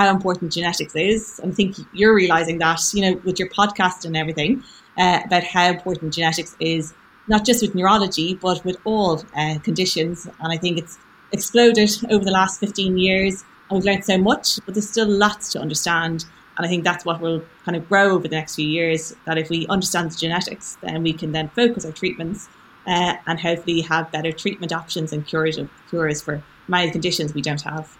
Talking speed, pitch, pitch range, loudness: 205 wpm, 175 Hz, 165-195 Hz, -20 LUFS